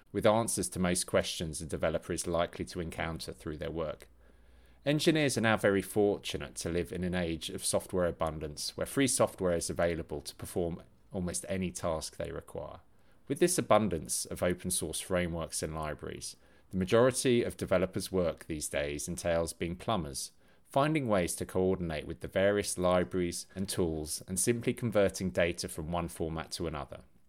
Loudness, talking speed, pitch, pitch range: -32 LUFS, 170 wpm, 90 Hz, 80-100 Hz